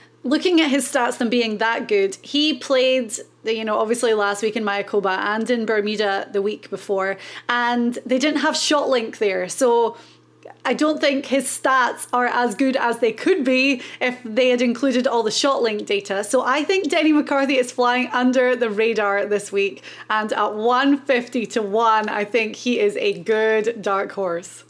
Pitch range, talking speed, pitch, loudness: 215-260 Hz, 180 wpm, 240 Hz, -20 LUFS